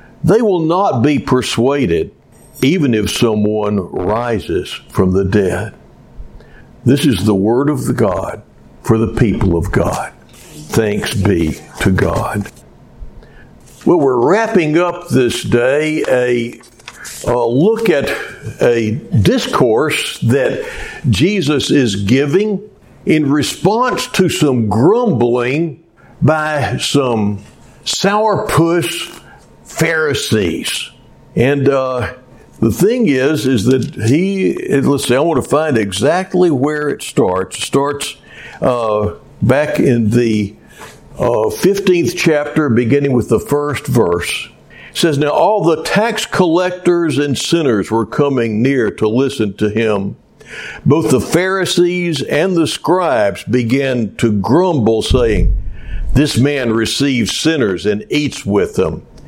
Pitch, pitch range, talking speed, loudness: 130 Hz, 110-165 Hz, 120 wpm, -14 LUFS